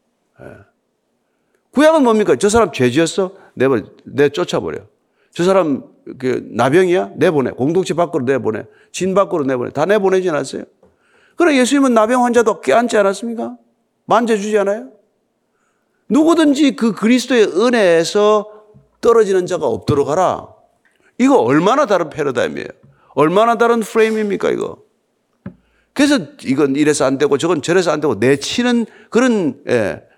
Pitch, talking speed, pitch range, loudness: 210 Hz, 315 characters per minute, 180-245 Hz, -15 LUFS